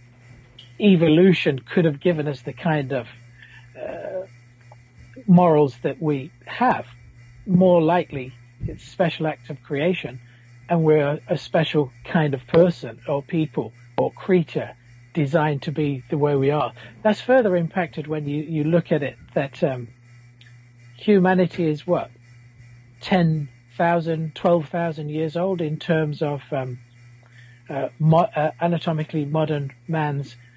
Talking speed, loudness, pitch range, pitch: 130 wpm, -22 LUFS, 125-170 Hz, 150 Hz